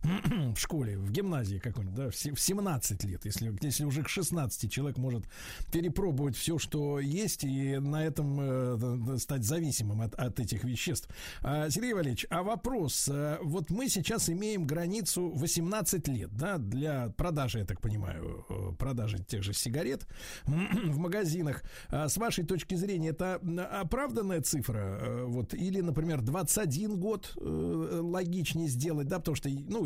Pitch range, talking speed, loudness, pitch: 120-175 Hz, 150 wpm, -33 LUFS, 150 Hz